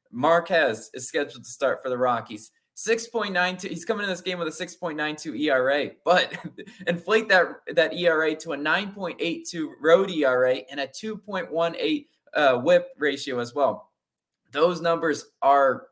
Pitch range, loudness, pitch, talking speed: 145-190 Hz, -24 LUFS, 170 Hz, 190 wpm